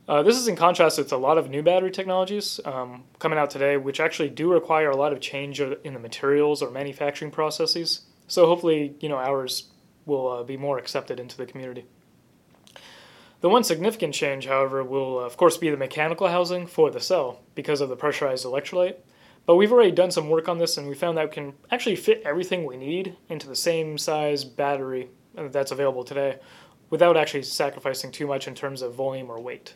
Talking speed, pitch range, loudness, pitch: 205 wpm, 135-170 Hz, -24 LUFS, 150 Hz